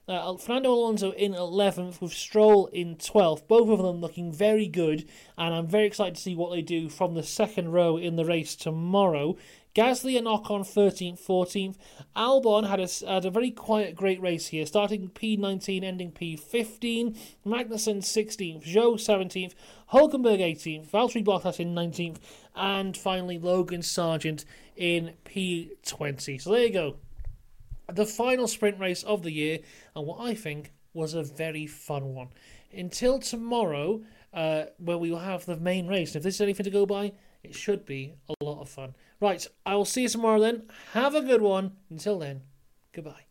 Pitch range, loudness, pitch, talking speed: 165-210 Hz, -27 LUFS, 185 Hz, 175 wpm